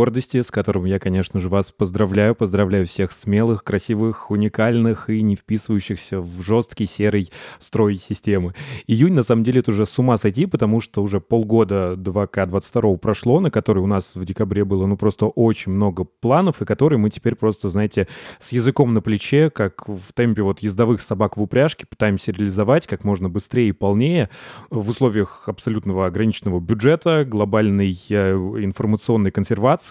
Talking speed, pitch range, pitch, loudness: 160 wpm, 100-115 Hz, 105 Hz, -19 LUFS